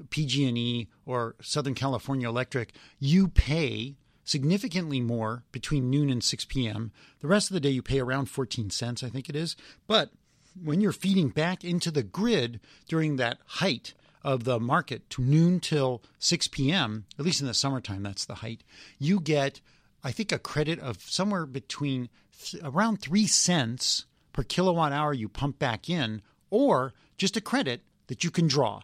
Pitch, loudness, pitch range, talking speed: 140 Hz, -28 LUFS, 125-160 Hz, 175 wpm